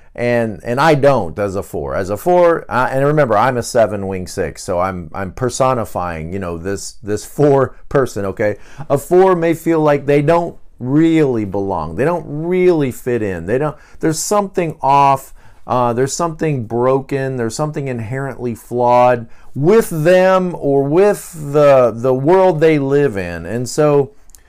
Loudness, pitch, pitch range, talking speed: -15 LUFS, 135 Hz, 110-155 Hz, 165 wpm